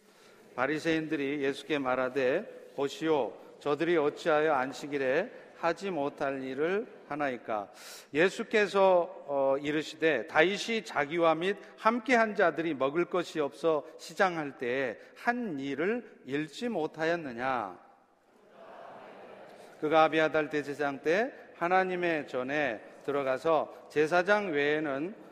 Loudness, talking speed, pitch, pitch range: -30 LUFS, 245 characters per minute, 155 Hz, 145-180 Hz